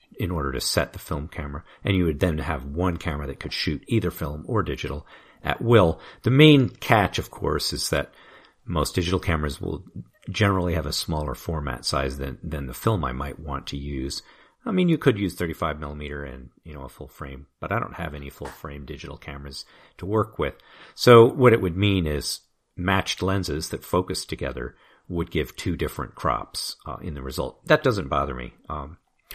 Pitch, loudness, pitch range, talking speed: 80 Hz, -24 LUFS, 70-95 Hz, 200 wpm